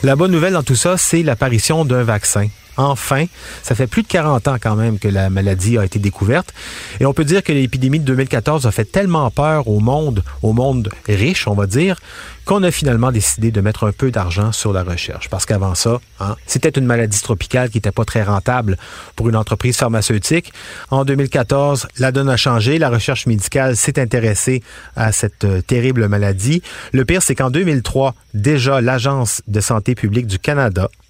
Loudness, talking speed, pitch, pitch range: -16 LUFS, 195 wpm, 125 Hz, 105-140 Hz